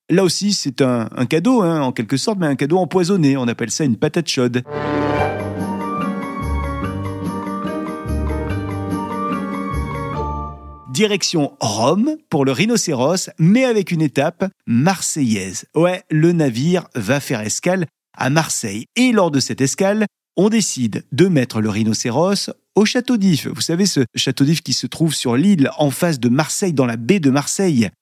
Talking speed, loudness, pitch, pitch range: 150 wpm, -18 LUFS, 140 Hz, 120-180 Hz